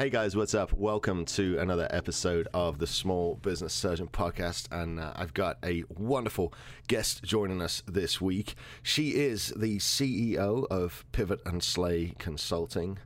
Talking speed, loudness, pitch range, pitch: 155 wpm, -31 LUFS, 85-105 Hz, 95 Hz